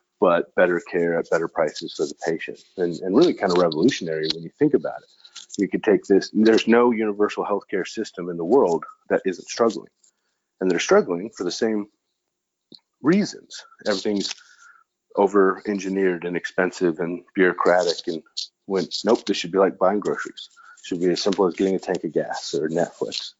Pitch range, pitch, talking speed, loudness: 95-120 Hz, 105 Hz, 180 wpm, -22 LUFS